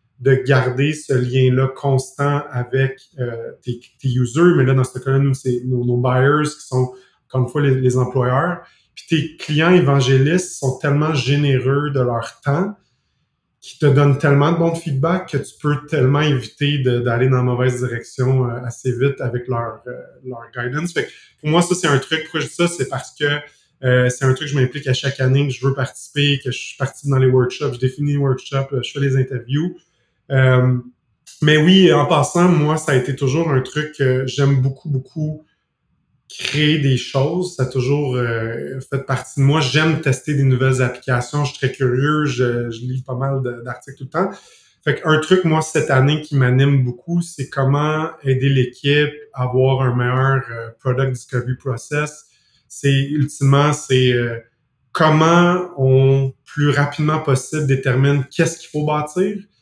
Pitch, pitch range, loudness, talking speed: 135 Hz, 130-150 Hz, -18 LUFS, 190 wpm